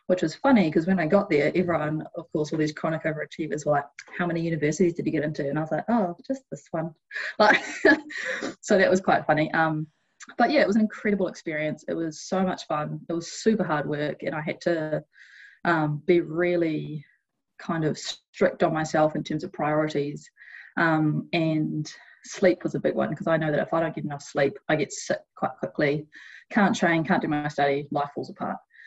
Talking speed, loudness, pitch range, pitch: 215 wpm, -25 LUFS, 150-185 Hz, 165 Hz